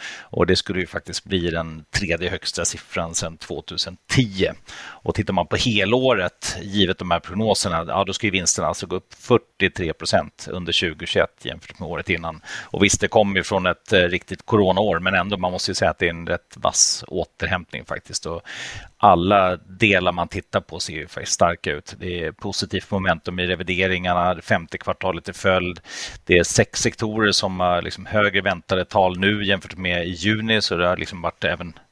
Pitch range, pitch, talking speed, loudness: 90-100 Hz, 95 Hz, 190 wpm, -21 LUFS